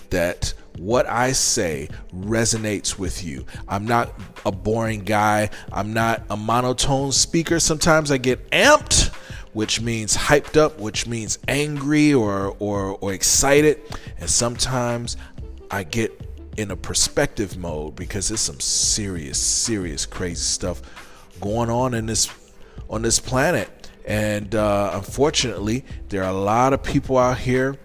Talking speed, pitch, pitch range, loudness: 140 wpm, 110 Hz, 100-125 Hz, -20 LUFS